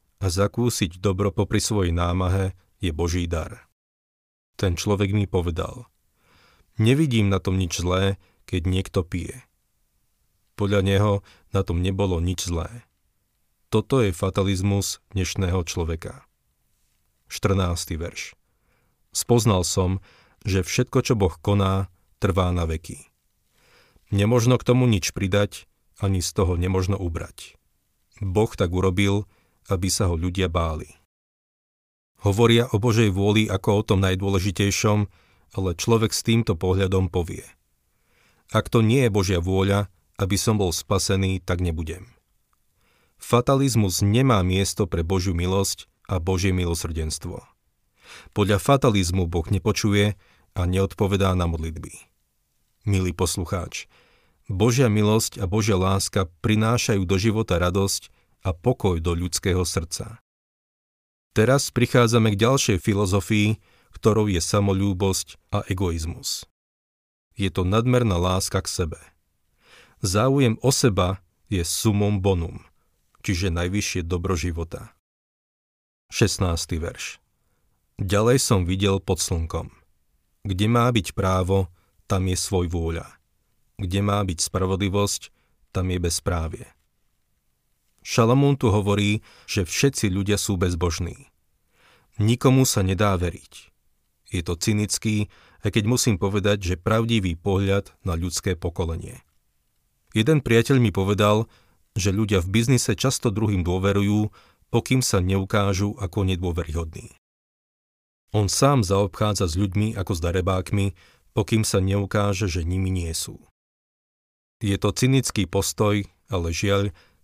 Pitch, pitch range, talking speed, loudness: 95 Hz, 90-105 Hz, 120 wpm, -23 LUFS